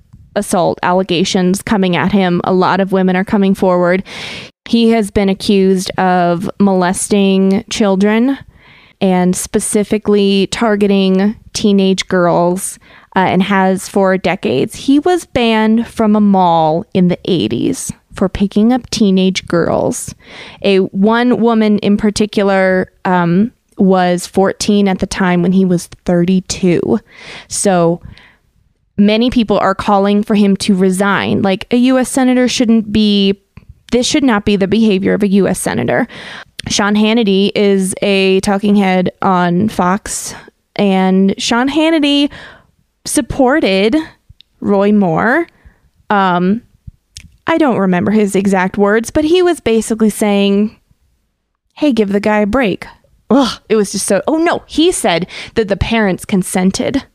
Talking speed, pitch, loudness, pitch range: 135 wpm, 200 Hz, -13 LUFS, 190-220 Hz